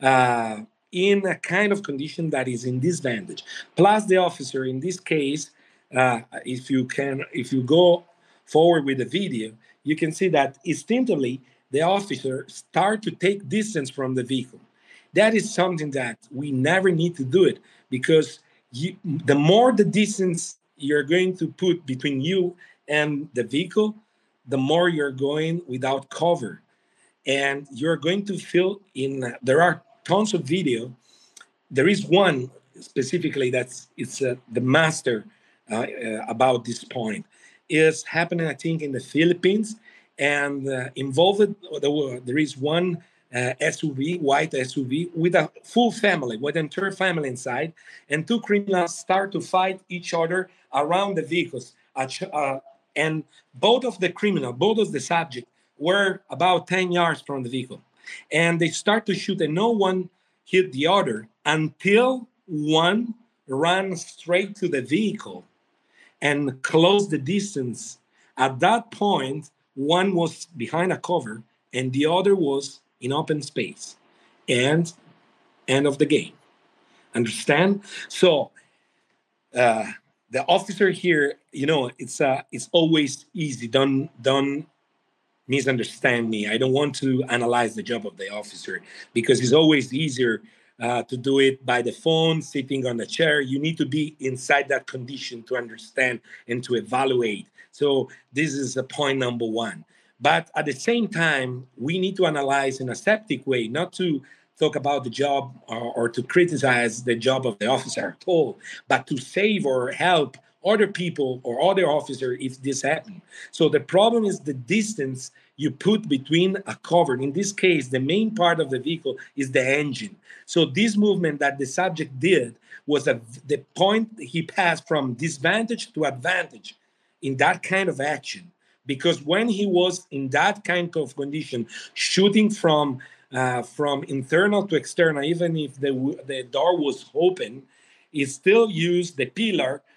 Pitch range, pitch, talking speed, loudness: 135-180 Hz, 150 Hz, 160 wpm, -23 LUFS